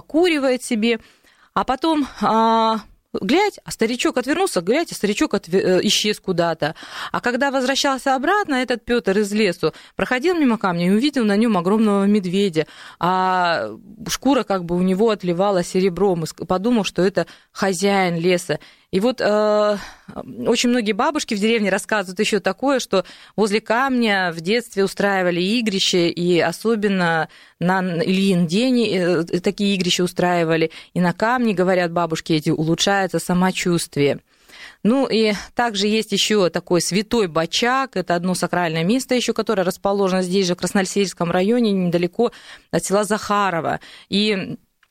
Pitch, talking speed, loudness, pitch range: 200 Hz, 140 wpm, -19 LUFS, 180-230 Hz